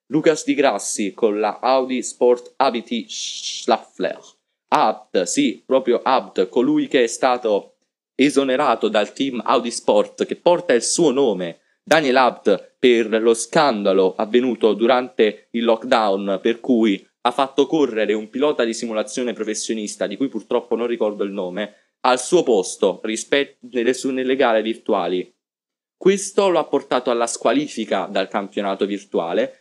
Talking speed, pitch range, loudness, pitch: 140 wpm, 115-150 Hz, -19 LUFS, 125 Hz